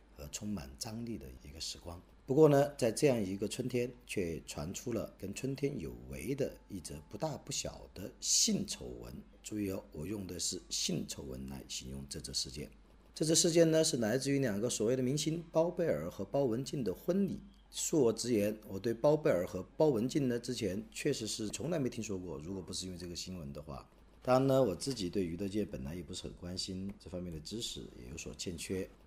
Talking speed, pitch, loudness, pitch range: 310 characters per minute, 100 Hz, -35 LUFS, 85-130 Hz